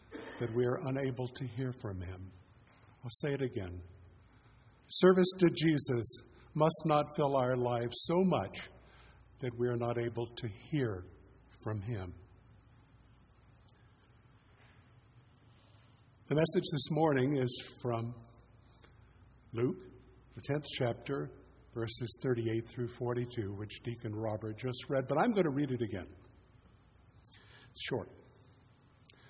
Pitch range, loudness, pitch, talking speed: 110-130 Hz, -35 LUFS, 120 Hz, 120 wpm